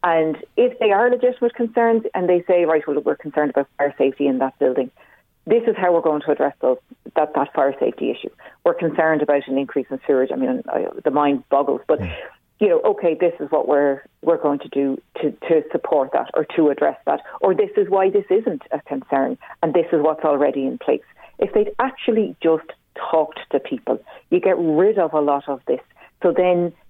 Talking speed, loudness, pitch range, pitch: 215 wpm, -20 LUFS, 145-220 Hz, 160 Hz